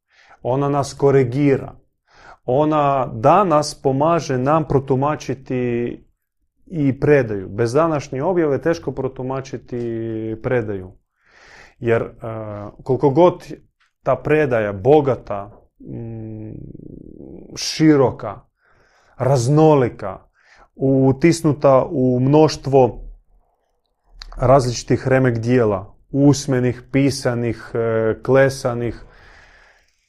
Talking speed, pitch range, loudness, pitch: 65 wpm, 120-145 Hz, -18 LUFS, 135 Hz